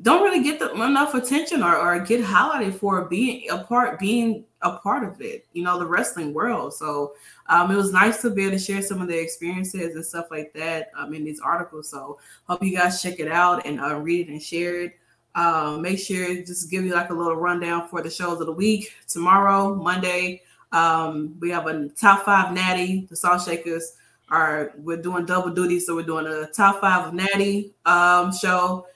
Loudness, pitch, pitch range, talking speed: -22 LUFS, 180 Hz, 165-195 Hz, 210 wpm